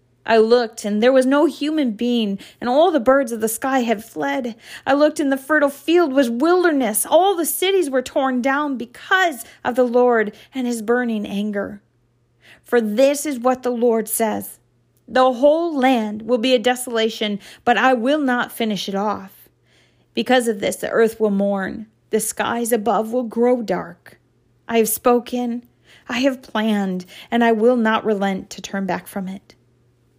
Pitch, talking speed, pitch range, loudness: 240 Hz, 175 wpm, 210-265 Hz, -19 LUFS